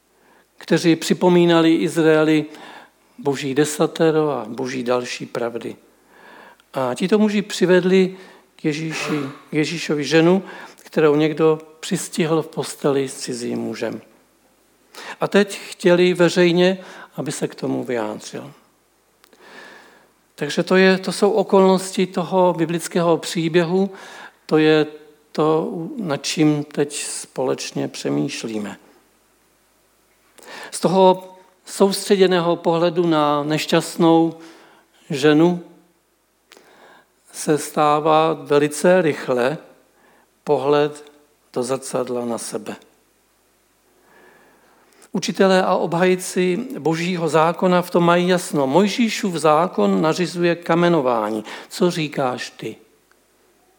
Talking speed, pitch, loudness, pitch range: 95 wpm, 165 Hz, -19 LUFS, 150-185 Hz